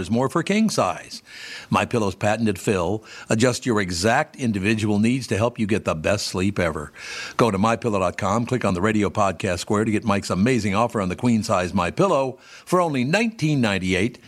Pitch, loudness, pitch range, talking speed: 110 Hz, -22 LUFS, 100-120 Hz, 195 wpm